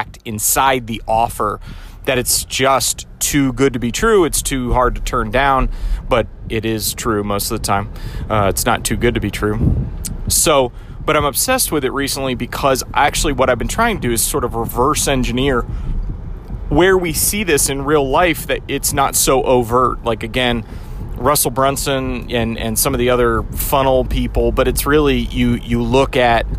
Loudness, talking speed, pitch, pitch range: -16 LUFS, 190 wpm, 125 Hz, 110-135 Hz